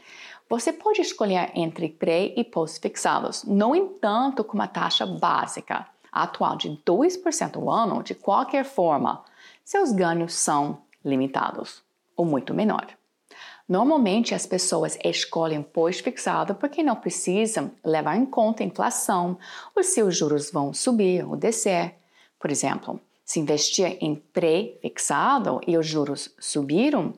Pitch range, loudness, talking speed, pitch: 160-250 Hz, -24 LUFS, 130 wpm, 185 Hz